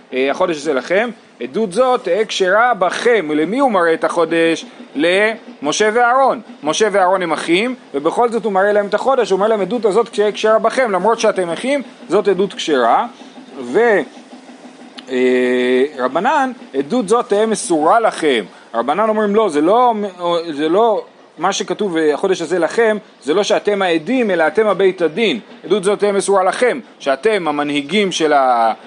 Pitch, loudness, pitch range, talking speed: 210 Hz, -15 LUFS, 170-245 Hz, 155 wpm